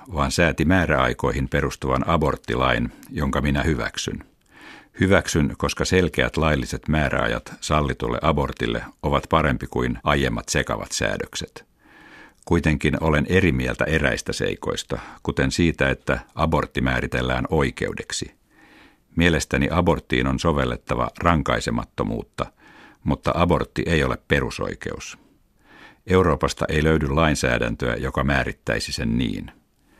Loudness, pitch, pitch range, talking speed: -22 LUFS, 70 Hz, 65-80 Hz, 100 wpm